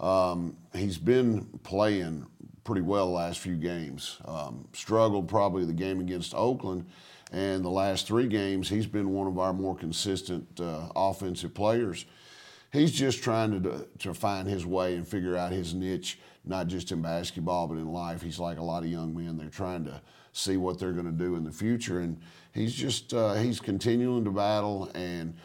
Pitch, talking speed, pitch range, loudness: 95 Hz, 190 wpm, 85-100 Hz, -30 LUFS